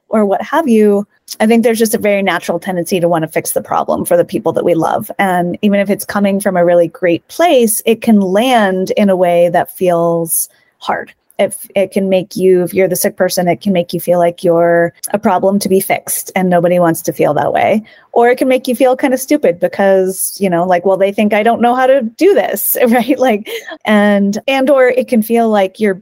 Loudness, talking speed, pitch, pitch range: -12 LUFS, 240 wpm, 200 Hz, 175-230 Hz